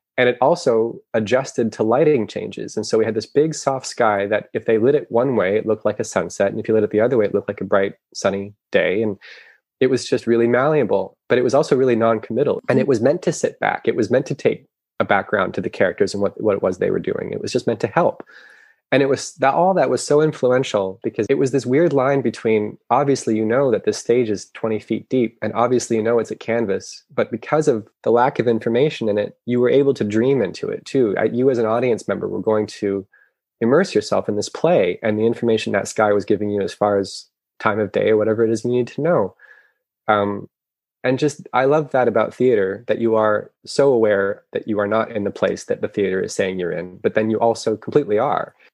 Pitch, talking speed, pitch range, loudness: 115 Hz, 250 wpm, 110-135 Hz, -19 LUFS